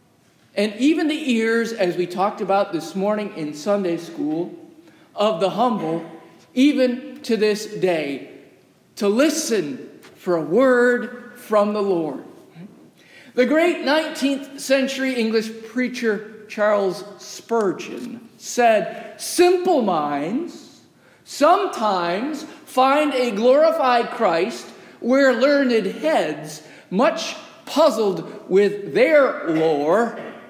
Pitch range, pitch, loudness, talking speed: 205-285 Hz, 235 Hz, -20 LUFS, 100 wpm